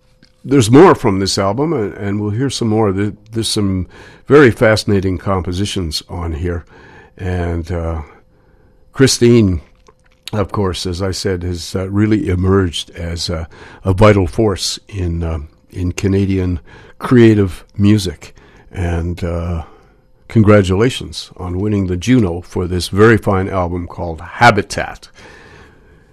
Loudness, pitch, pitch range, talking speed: -15 LUFS, 95 Hz, 90-105 Hz, 125 wpm